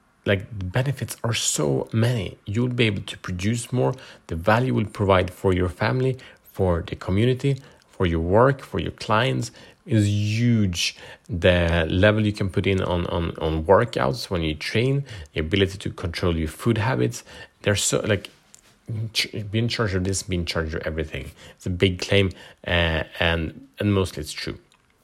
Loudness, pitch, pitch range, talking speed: -23 LUFS, 95 Hz, 85-110 Hz, 175 wpm